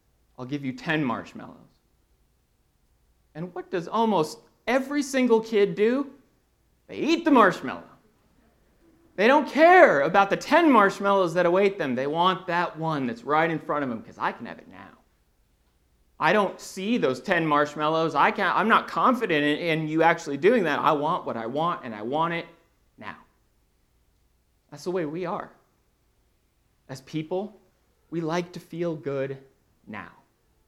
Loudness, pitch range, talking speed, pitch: -23 LUFS, 145-200 Hz, 160 wpm, 170 Hz